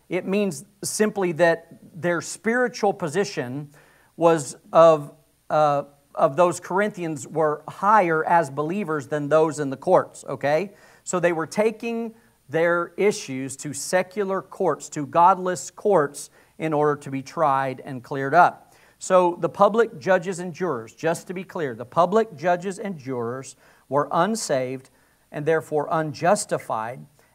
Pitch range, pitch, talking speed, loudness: 145-185 Hz, 165 Hz, 140 wpm, -23 LUFS